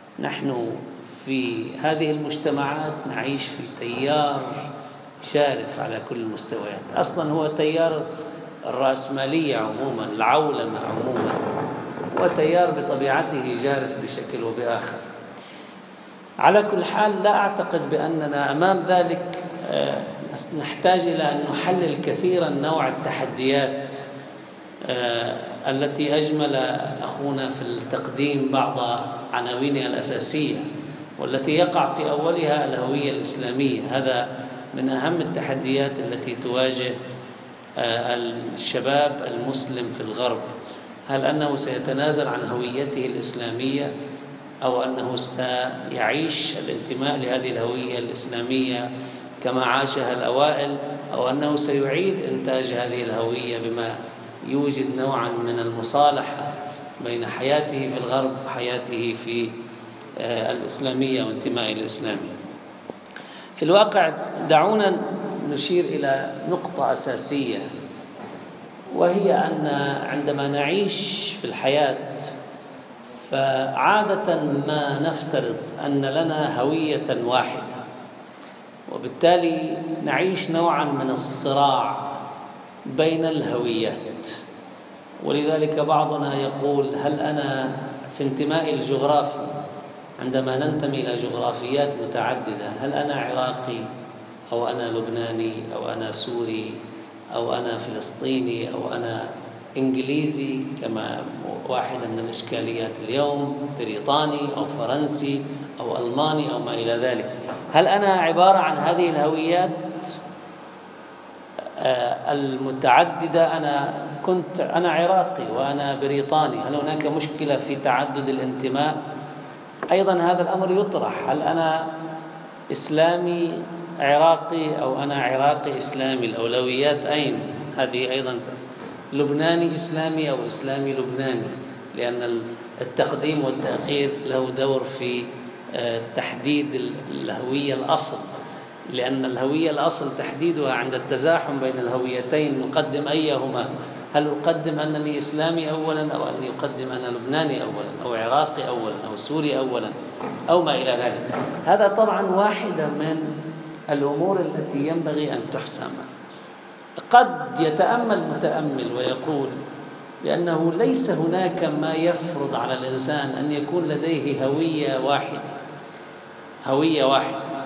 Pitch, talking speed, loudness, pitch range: 145 Hz, 100 wpm, -23 LUFS, 130-155 Hz